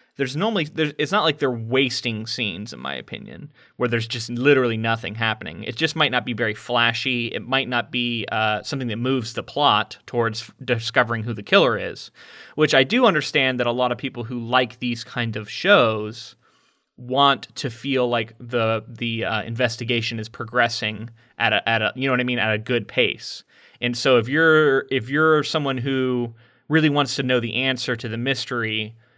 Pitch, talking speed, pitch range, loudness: 125 Hz, 195 wpm, 115-135 Hz, -21 LUFS